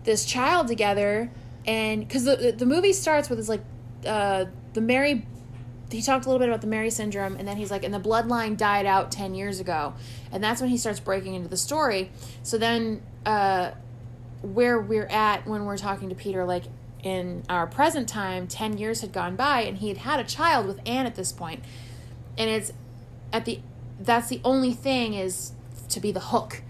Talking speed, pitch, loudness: 200 wpm, 200 Hz, -26 LUFS